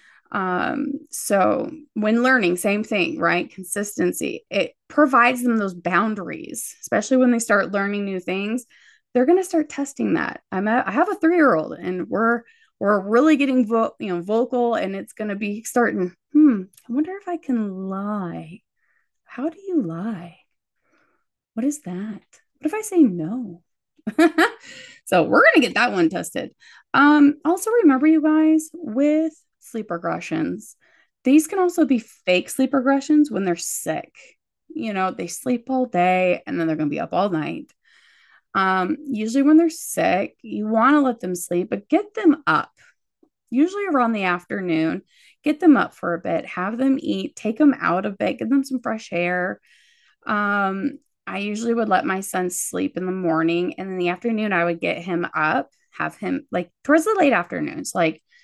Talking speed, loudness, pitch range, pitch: 180 wpm, -21 LUFS, 190-300 Hz, 235 Hz